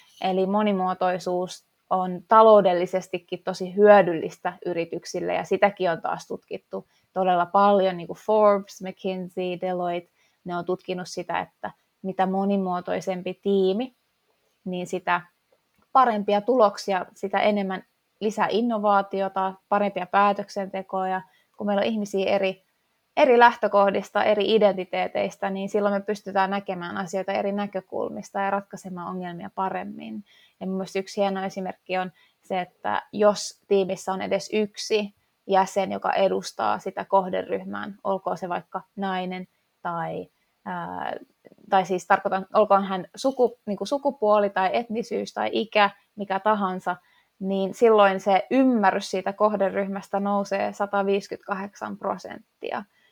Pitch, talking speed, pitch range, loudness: 195 Hz, 120 wpm, 185-205 Hz, -24 LUFS